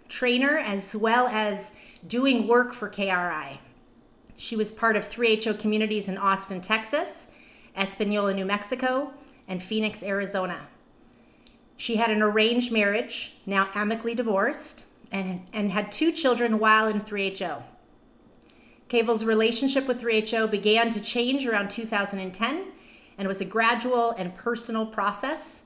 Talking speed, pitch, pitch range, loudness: 130 wpm, 220 Hz, 200-240 Hz, -25 LUFS